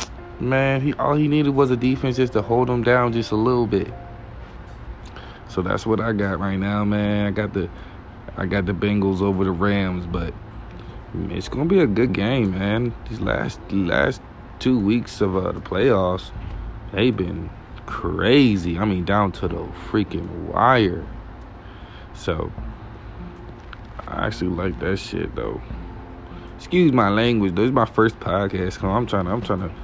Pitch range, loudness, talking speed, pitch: 90-115 Hz, -21 LUFS, 165 wpm, 100 Hz